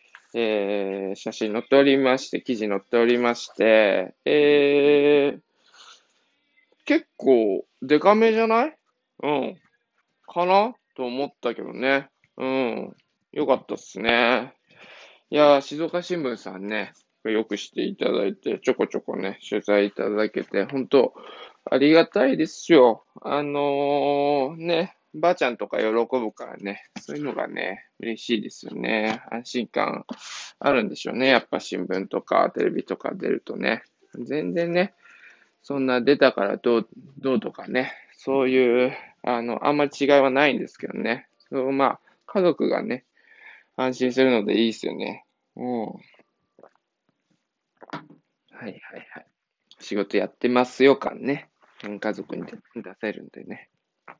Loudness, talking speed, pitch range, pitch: -23 LUFS, 260 characters per minute, 115-145 Hz, 130 Hz